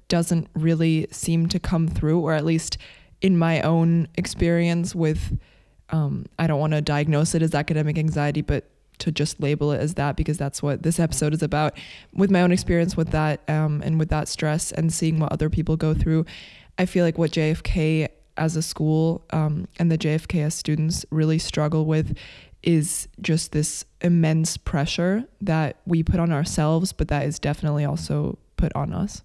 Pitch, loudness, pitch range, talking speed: 160 Hz, -23 LUFS, 150-165 Hz, 185 wpm